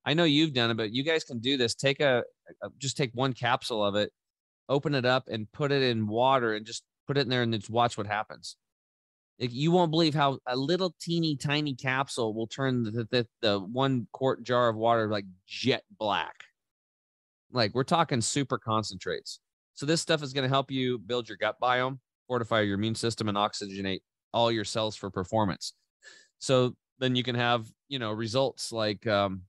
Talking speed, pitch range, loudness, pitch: 200 wpm, 110-135 Hz, -29 LUFS, 125 Hz